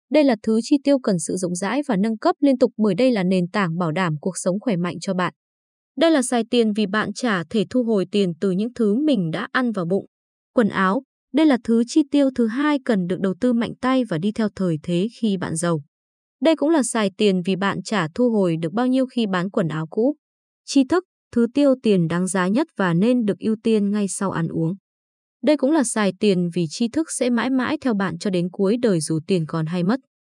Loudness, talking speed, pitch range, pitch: -21 LUFS, 250 wpm, 185-255 Hz, 215 Hz